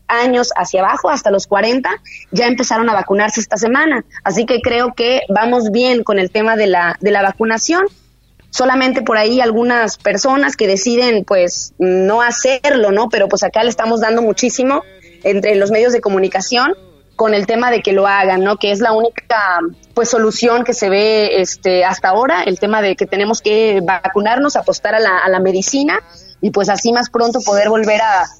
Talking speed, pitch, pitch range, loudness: 190 wpm, 220 Hz, 200-240 Hz, -13 LUFS